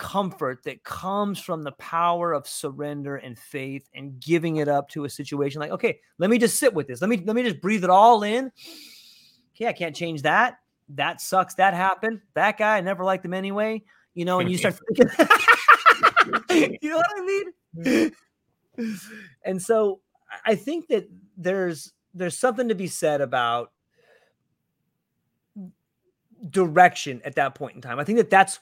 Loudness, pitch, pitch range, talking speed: -22 LUFS, 185 Hz, 155-225 Hz, 175 wpm